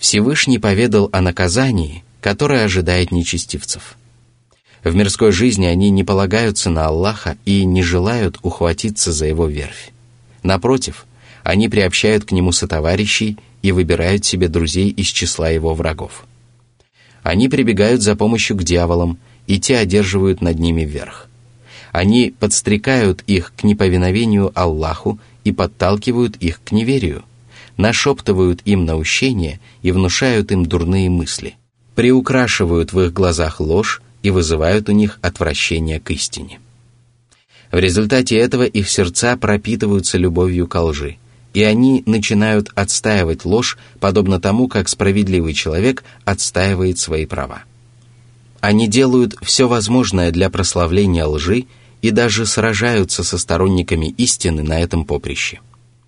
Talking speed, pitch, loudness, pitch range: 125 wpm, 100 Hz, -15 LUFS, 90-120 Hz